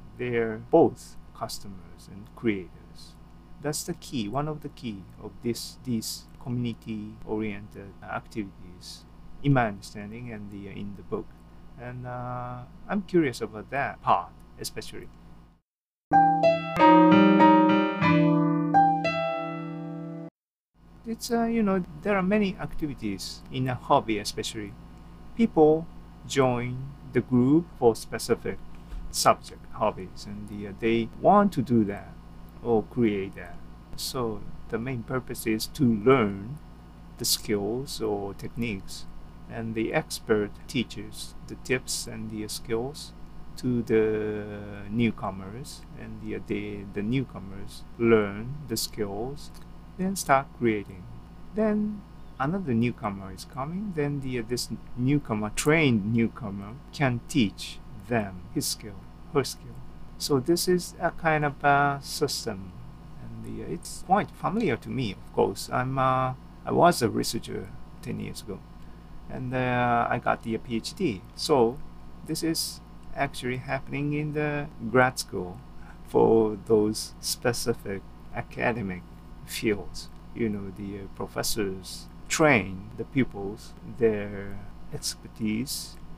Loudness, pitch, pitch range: -27 LUFS, 120 Hz, 105-145 Hz